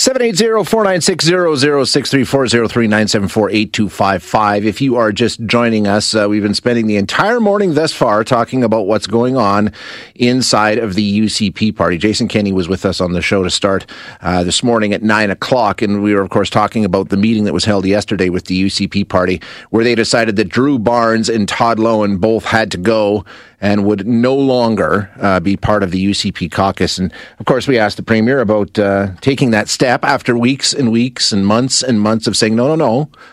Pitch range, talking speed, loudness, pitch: 100-120 Hz, 230 wpm, -13 LUFS, 110 Hz